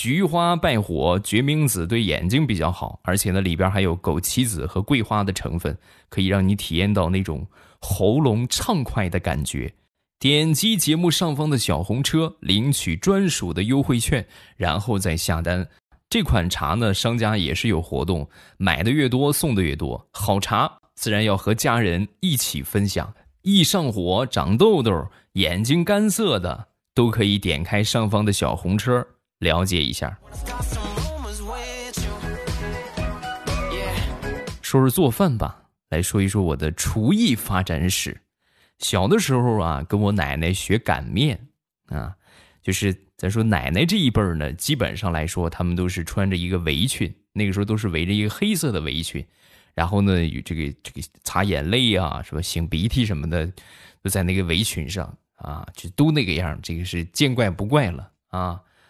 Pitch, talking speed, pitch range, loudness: 100 Hz, 240 characters per minute, 85-120 Hz, -22 LUFS